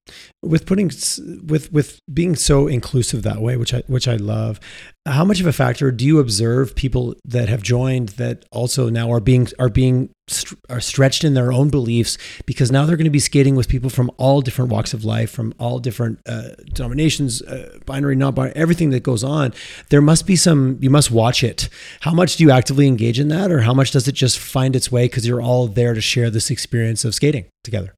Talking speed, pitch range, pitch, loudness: 225 wpm, 120-140 Hz, 130 Hz, -17 LUFS